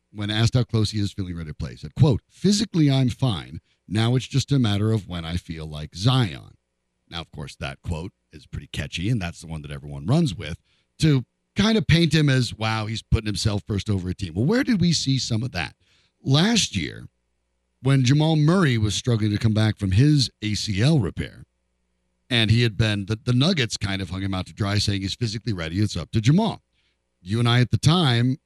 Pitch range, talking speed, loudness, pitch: 90-130 Hz, 225 wpm, -22 LUFS, 110 Hz